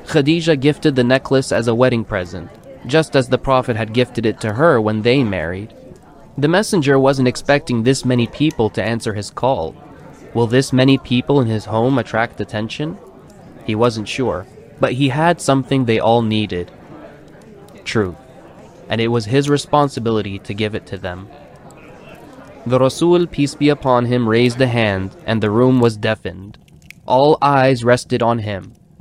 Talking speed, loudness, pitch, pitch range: 165 wpm, -16 LUFS, 125 Hz, 110-135 Hz